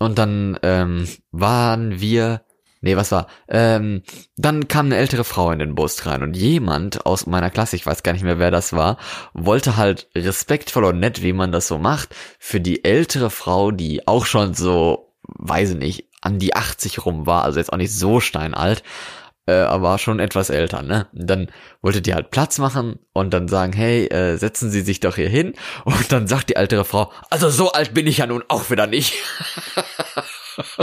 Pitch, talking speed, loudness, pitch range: 100 Hz, 195 wpm, -19 LUFS, 90-120 Hz